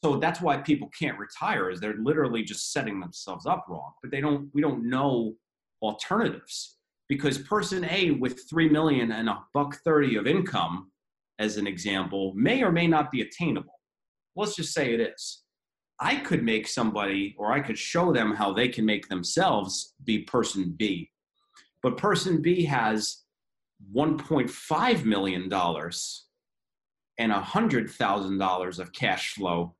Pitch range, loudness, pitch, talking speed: 100-150 Hz, -27 LUFS, 120 Hz, 155 wpm